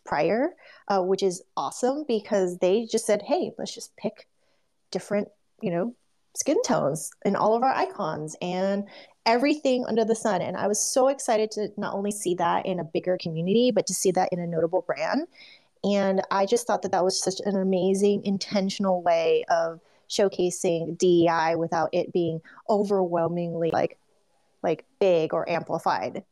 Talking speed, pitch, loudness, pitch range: 170 wpm, 195 Hz, -25 LUFS, 175-215 Hz